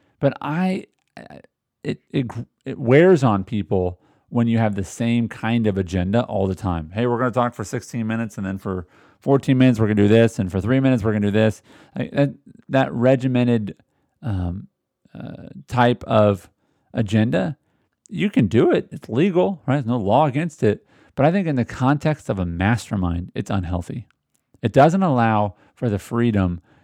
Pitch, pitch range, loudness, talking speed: 115 Hz, 100-135 Hz, -20 LUFS, 185 wpm